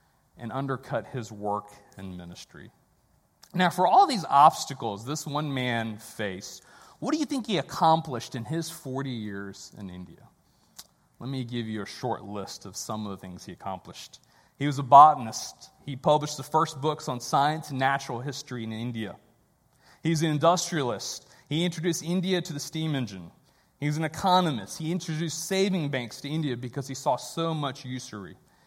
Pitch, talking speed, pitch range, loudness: 135 Hz, 170 wpm, 115-160 Hz, -27 LUFS